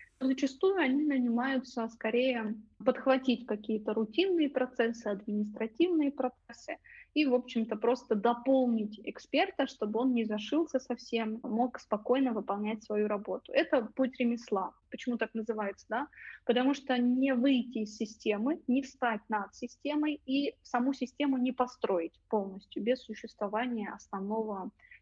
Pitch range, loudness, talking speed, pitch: 220-265 Hz, -32 LUFS, 125 wpm, 245 Hz